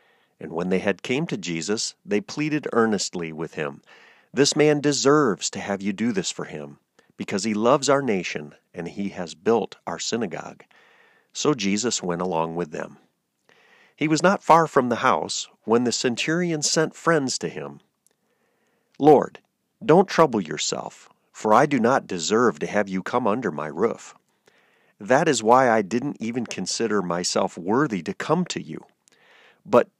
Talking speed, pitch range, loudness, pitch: 165 wpm, 100-150 Hz, -23 LUFS, 120 Hz